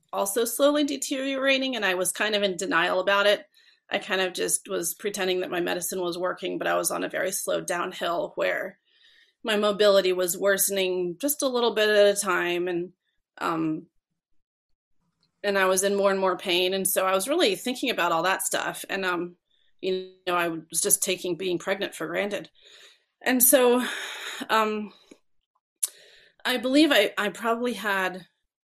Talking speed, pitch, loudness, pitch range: 175 wpm, 195 Hz, -25 LUFS, 185-235 Hz